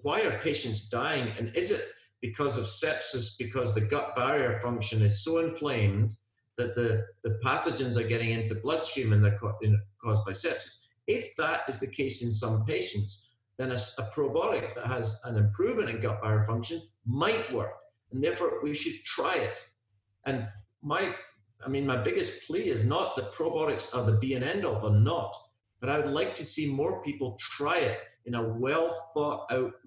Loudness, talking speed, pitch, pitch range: -30 LUFS, 190 wpm, 120 Hz, 110-145 Hz